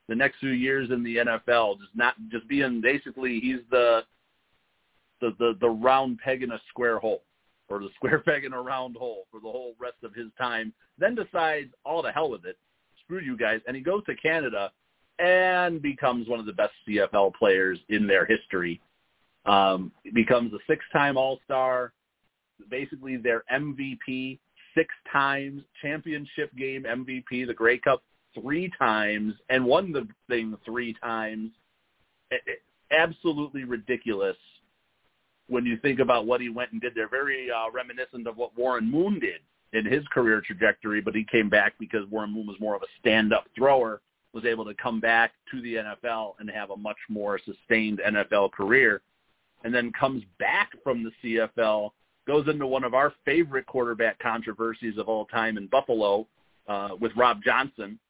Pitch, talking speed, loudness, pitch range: 120 Hz, 175 wpm, -26 LUFS, 110-135 Hz